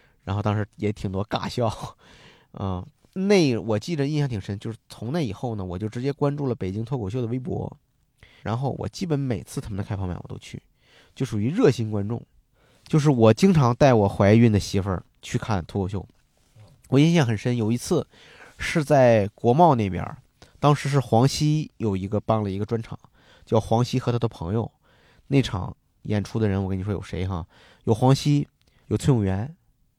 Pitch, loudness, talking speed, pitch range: 115 Hz, -23 LUFS, 275 characters per minute, 105-135 Hz